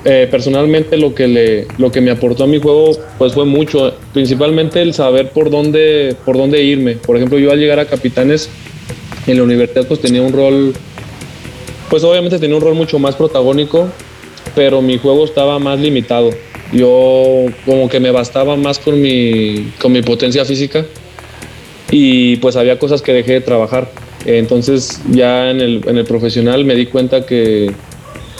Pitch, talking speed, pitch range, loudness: 130 Hz, 175 wpm, 125-145 Hz, -11 LUFS